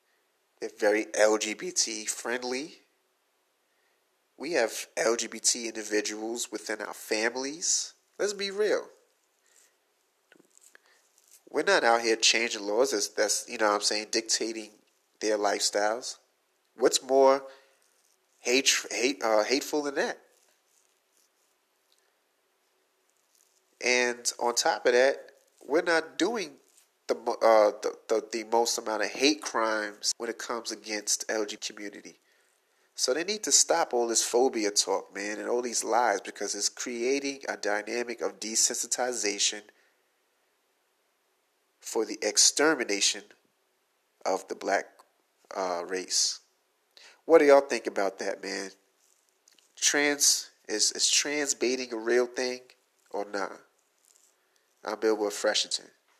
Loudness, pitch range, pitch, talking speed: -27 LUFS, 105-135 Hz, 115 Hz, 120 wpm